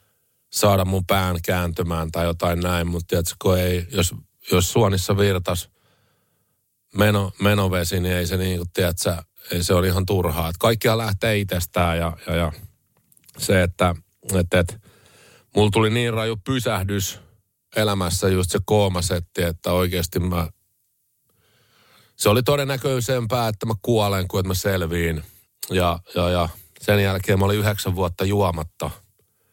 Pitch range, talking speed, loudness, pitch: 90-105 Hz, 130 wpm, -22 LUFS, 95 Hz